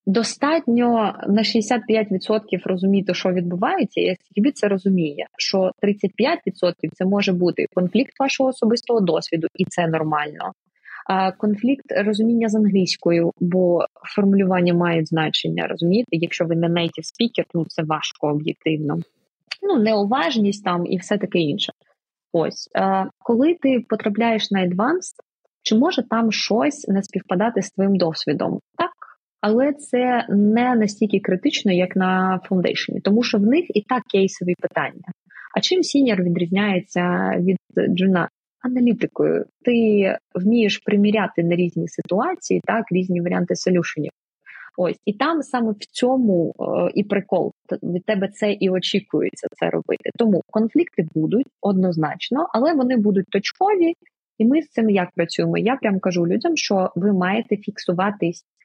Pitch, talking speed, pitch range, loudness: 200 Hz, 135 wpm, 180-230 Hz, -20 LUFS